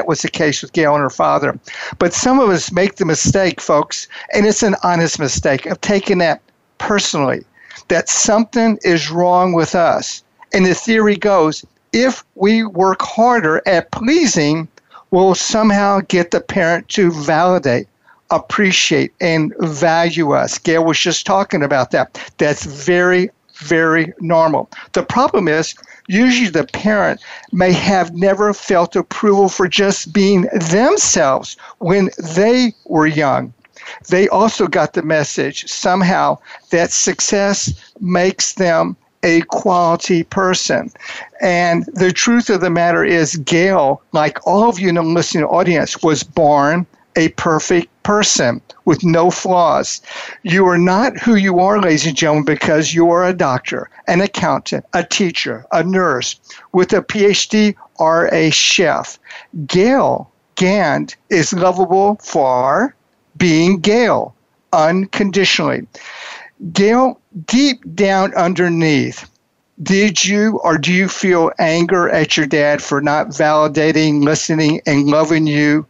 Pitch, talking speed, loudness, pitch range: 180 Hz, 135 wpm, -14 LUFS, 160-200 Hz